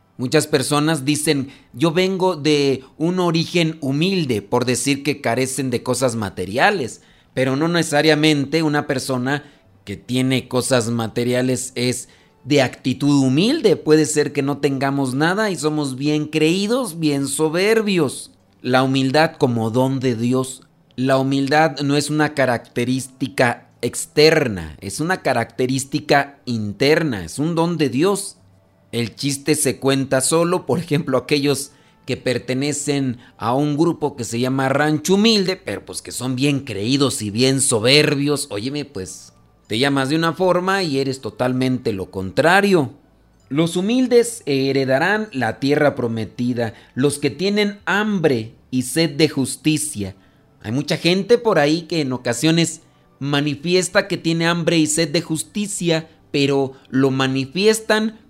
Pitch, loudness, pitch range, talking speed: 140 Hz, -19 LUFS, 130-160 Hz, 140 wpm